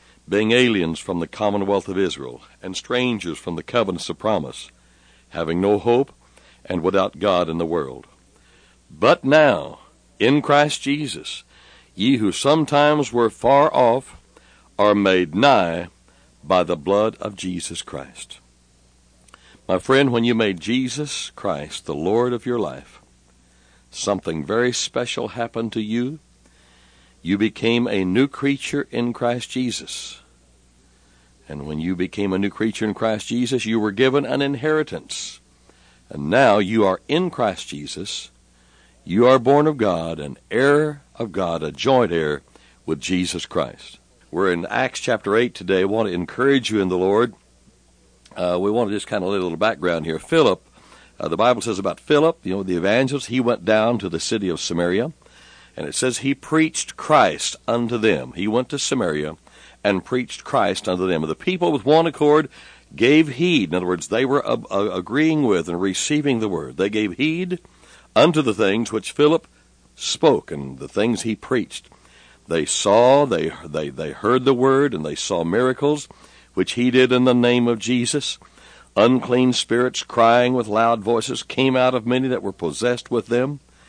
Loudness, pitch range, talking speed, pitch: -20 LUFS, 85-125 Hz, 170 wpm, 110 Hz